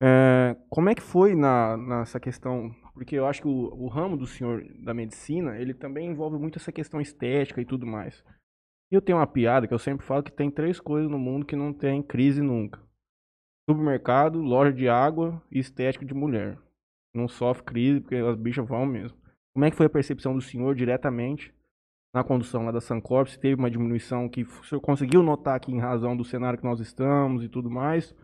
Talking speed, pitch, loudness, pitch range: 210 wpm, 130 Hz, -26 LUFS, 120-145 Hz